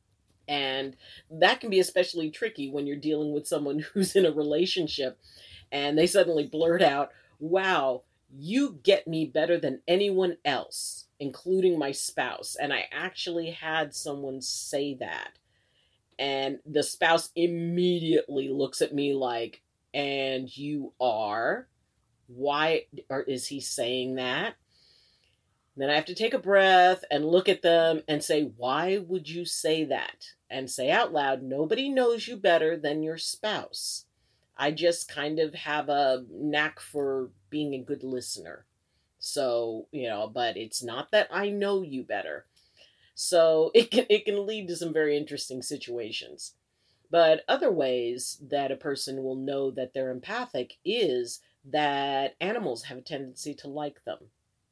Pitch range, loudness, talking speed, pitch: 135-175 Hz, -28 LUFS, 150 wpm, 150 Hz